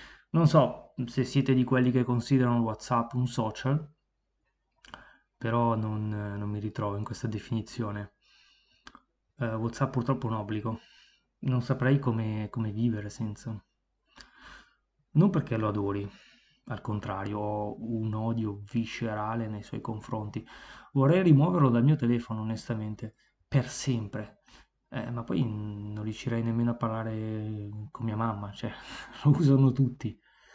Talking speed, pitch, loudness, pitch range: 130 wpm, 115 Hz, -29 LUFS, 105-125 Hz